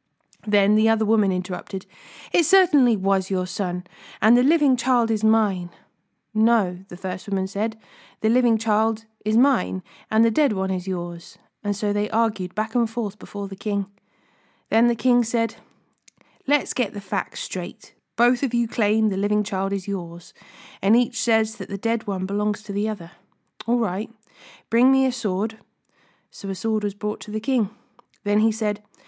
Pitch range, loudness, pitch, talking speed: 195-230 Hz, -23 LUFS, 215 Hz, 180 wpm